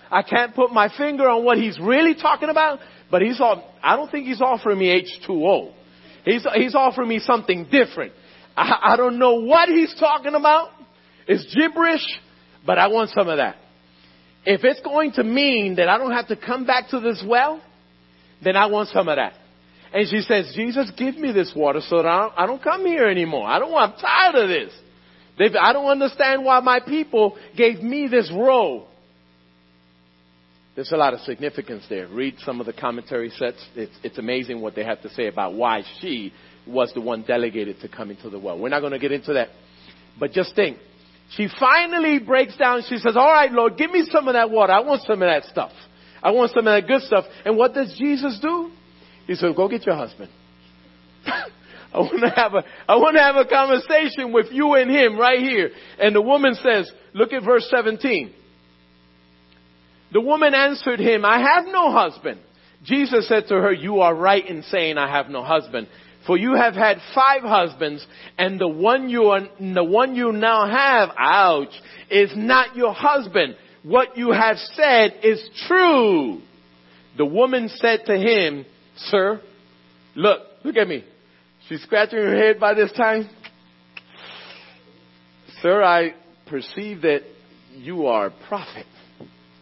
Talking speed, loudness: 185 wpm, -19 LUFS